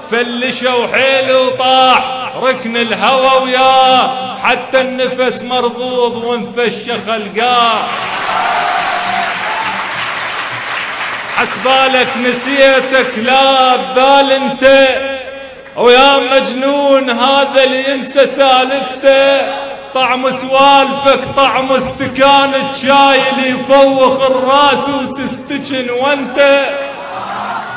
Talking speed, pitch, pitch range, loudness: 70 wpm, 260 Hz, 255-270 Hz, -11 LUFS